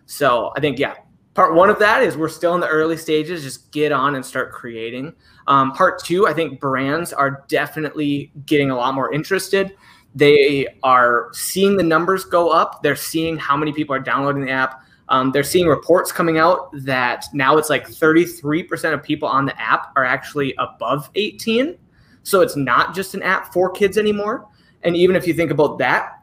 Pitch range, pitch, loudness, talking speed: 135-175 Hz, 150 Hz, -18 LUFS, 195 wpm